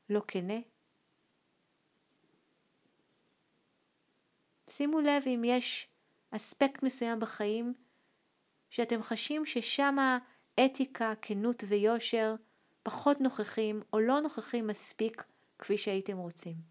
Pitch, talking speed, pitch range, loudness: 230 Hz, 85 wpm, 215-260 Hz, -33 LUFS